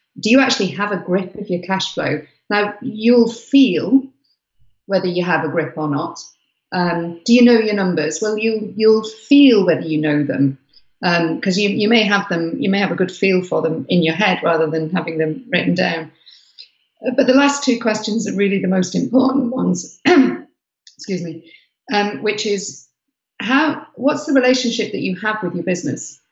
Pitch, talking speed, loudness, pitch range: 200 Hz, 185 wpm, -17 LUFS, 170-235 Hz